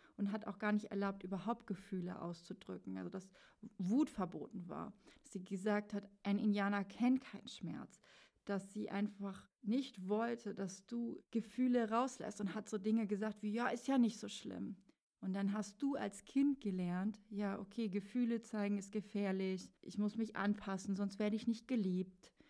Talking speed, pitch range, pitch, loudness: 175 wpm, 195-225 Hz, 205 Hz, -41 LUFS